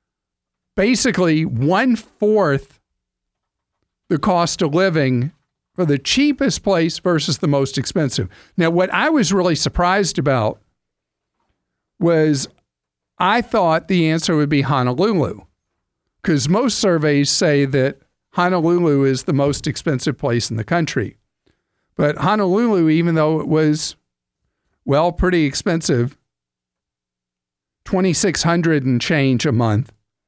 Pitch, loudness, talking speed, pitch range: 150 Hz, -17 LUFS, 120 wpm, 125-175 Hz